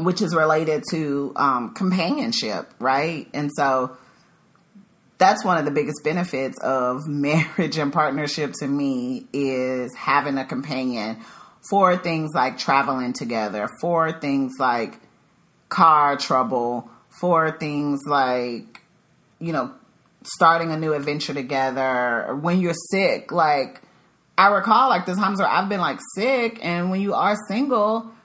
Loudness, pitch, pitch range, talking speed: -22 LUFS, 155 Hz, 135-185 Hz, 135 wpm